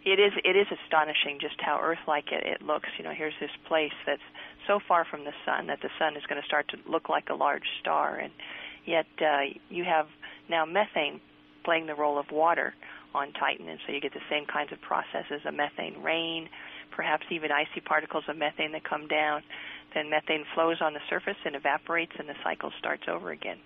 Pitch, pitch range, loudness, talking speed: 155 Hz, 150-170 Hz, -30 LUFS, 215 wpm